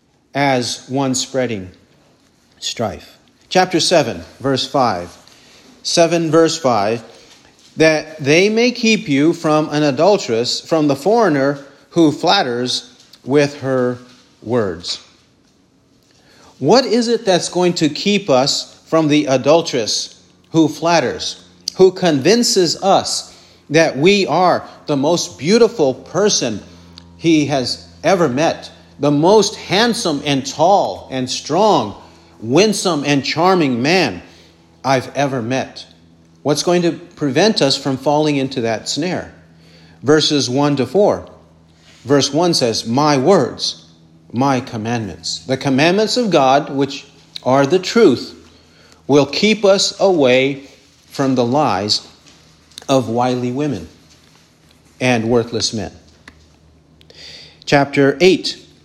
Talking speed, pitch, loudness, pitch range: 115 wpm, 135 Hz, -15 LUFS, 110-160 Hz